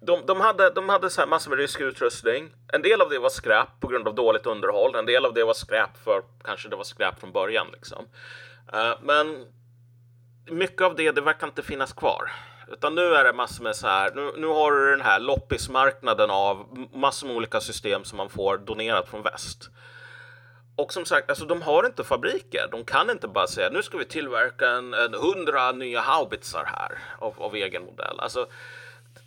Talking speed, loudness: 205 wpm, -24 LUFS